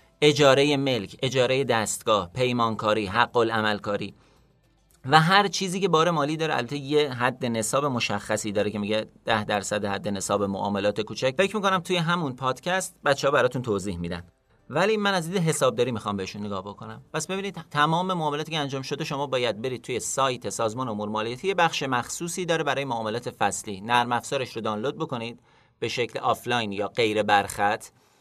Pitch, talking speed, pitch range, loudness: 125 Hz, 165 wpm, 105-150 Hz, -25 LUFS